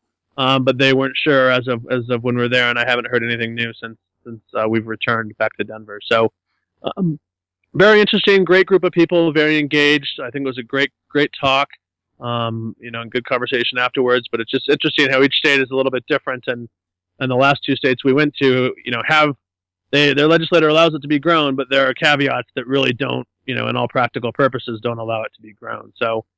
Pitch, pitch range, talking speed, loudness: 130 Hz, 115-145 Hz, 235 wpm, -17 LUFS